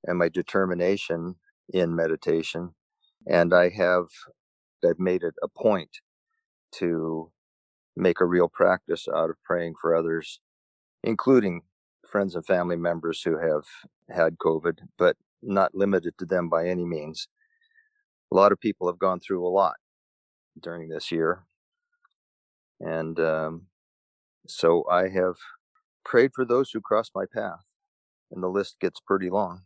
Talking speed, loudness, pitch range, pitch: 140 wpm, -25 LUFS, 80-100 Hz, 90 Hz